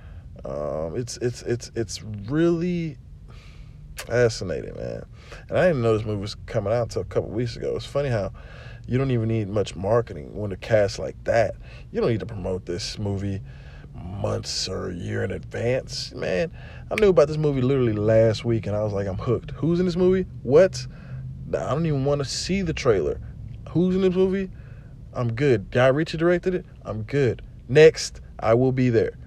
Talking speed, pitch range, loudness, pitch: 195 wpm, 105-140 Hz, -24 LUFS, 120 Hz